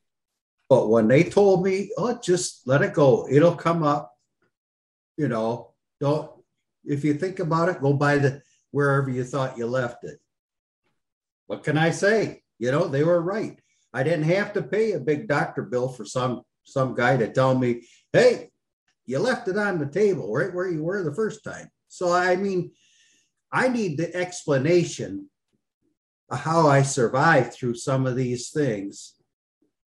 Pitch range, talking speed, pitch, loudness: 130-180 Hz, 170 wpm, 150 Hz, -23 LUFS